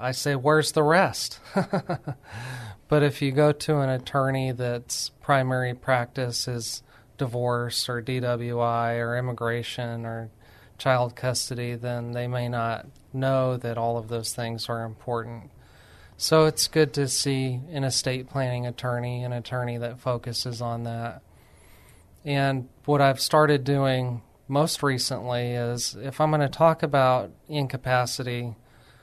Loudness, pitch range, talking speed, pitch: -25 LUFS, 120-140 Hz, 135 wpm, 125 Hz